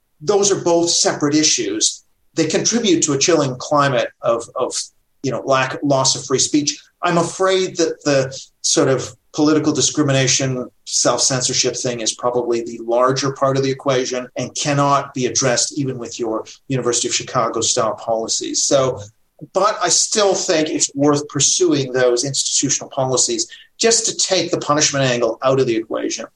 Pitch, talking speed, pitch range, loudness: 145 Hz, 165 wpm, 130-185 Hz, -17 LUFS